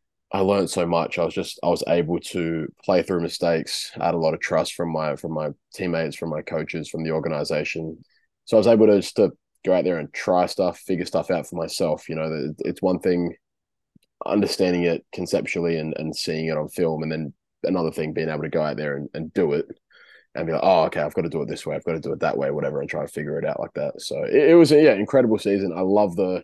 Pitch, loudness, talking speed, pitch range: 85 Hz, -23 LUFS, 265 wpm, 80-105 Hz